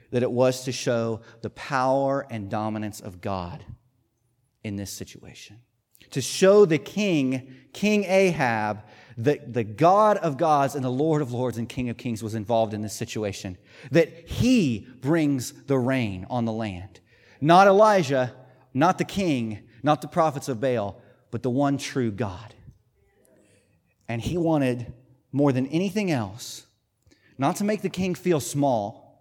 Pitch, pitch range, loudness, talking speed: 125 Hz, 115-145 Hz, -24 LUFS, 155 wpm